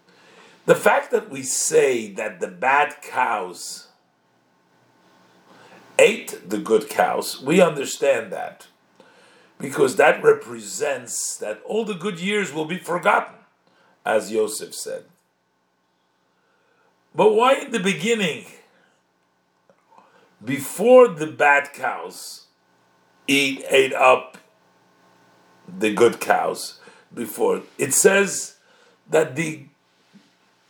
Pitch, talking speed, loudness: 185 Hz, 100 wpm, -20 LUFS